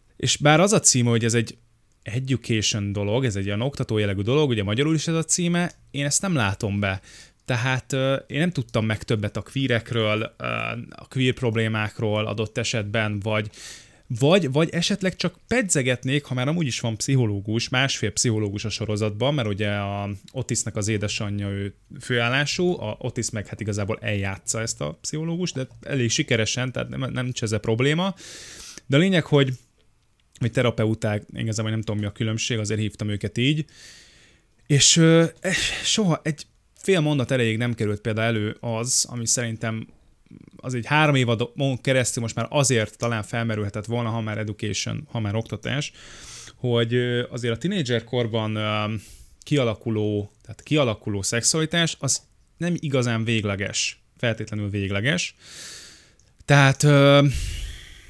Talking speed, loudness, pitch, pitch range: 155 wpm, -23 LUFS, 115 Hz, 110-140 Hz